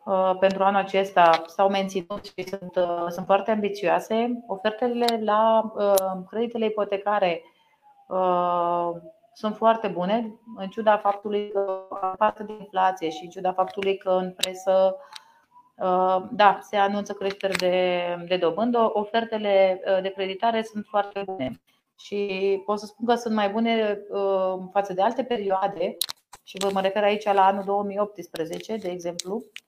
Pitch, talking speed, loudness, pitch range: 195 Hz, 150 wpm, -24 LUFS, 185-215 Hz